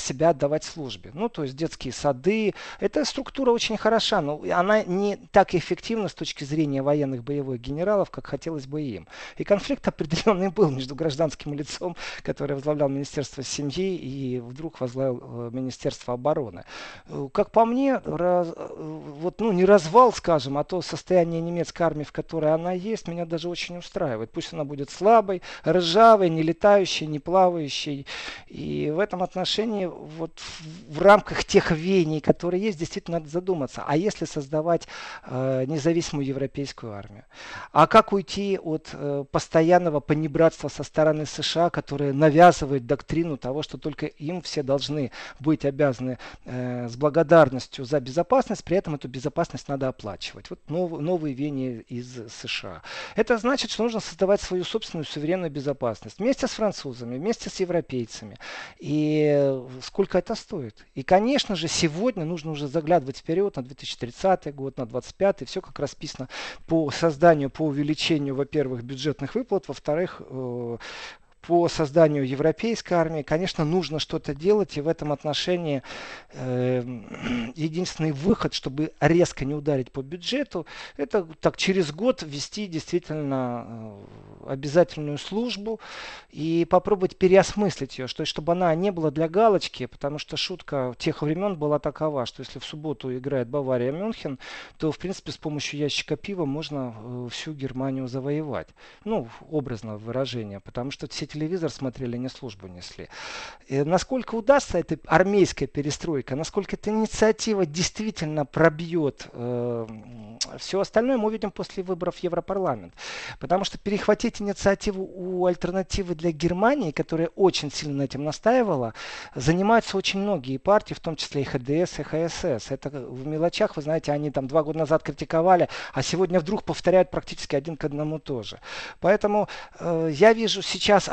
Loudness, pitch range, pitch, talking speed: -25 LUFS, 140-185 Hz, 160 Hz, 145 wpm